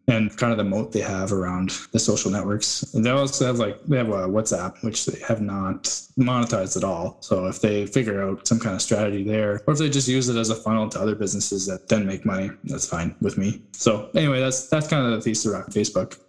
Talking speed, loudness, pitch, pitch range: 245 wpm, -23 LUFS, 110 Hz, 100-125 Hz